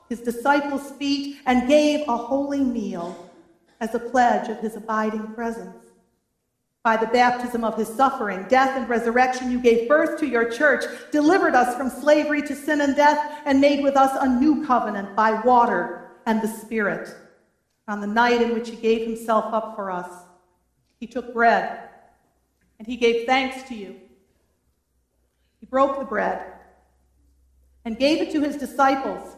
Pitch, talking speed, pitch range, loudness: 235 Hz, 165 wpm, 215-270 Hz, -21 LUFS